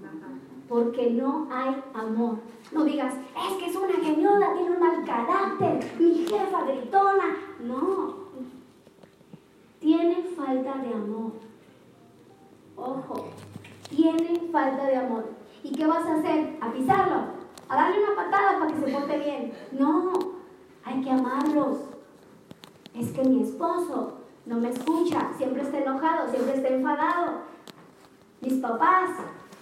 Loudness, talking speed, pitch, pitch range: -26 LUFS, 130 wpm, 300 Hz, 260-345 Hz